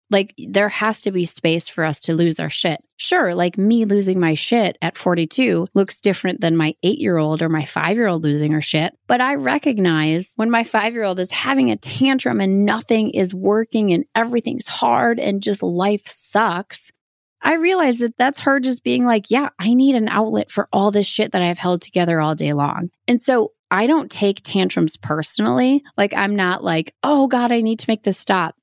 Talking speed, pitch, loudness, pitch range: 215 wpm, 200 Hz, -18 LUFS, 175-235 Hz